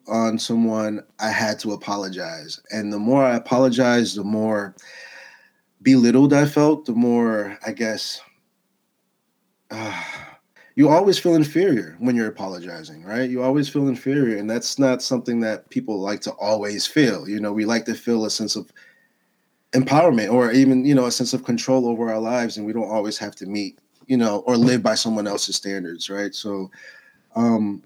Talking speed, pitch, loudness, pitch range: 175 wpm, 115 Hz, -20 LUFS, 105-130 Hz